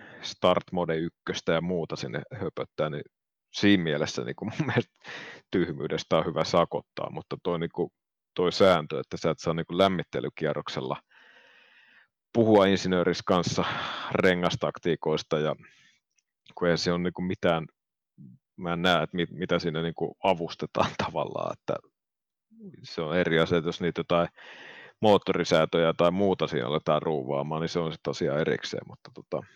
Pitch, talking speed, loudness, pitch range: 85 Hz, 150 wpm, -27 LUFS, 80-90 Hz